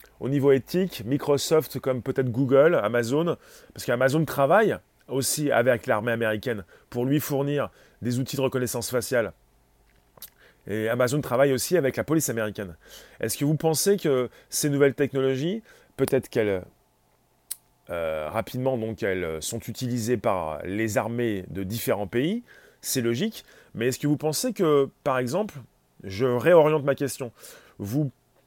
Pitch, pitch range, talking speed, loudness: 130 Hz, 115-145 Hz, 145 wpm, -25 LUFS